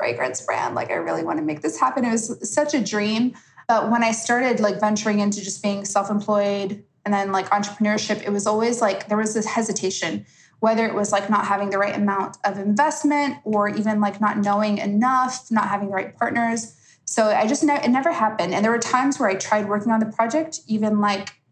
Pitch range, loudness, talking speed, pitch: 205-230 Hz, -22 LUFS, 225 wpm, 210 Hz